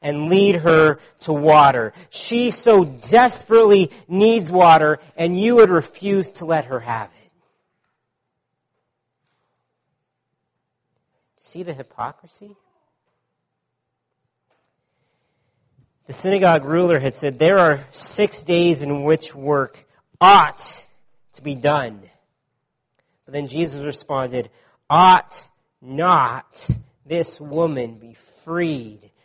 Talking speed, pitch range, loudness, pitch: 100 wpm, 135-180 Hz, -16 LUFS, 155 Hz